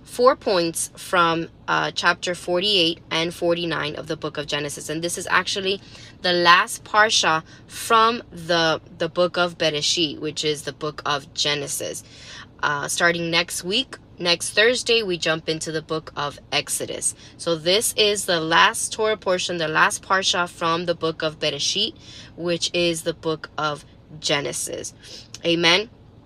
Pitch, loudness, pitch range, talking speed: 170 Hz, -21 LUFS, 155-180 Hz, 155 wpm